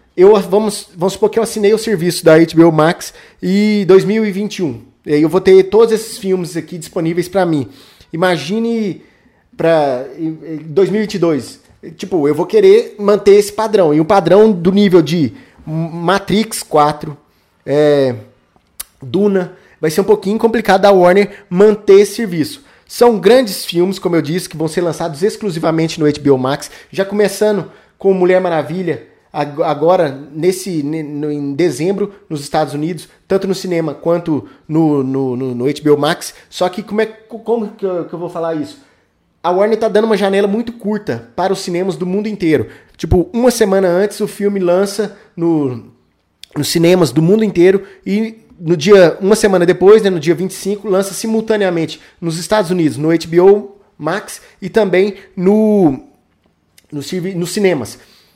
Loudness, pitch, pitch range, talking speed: -14 LUFS, 185 Hz, 160-205 Hz, 155 wpm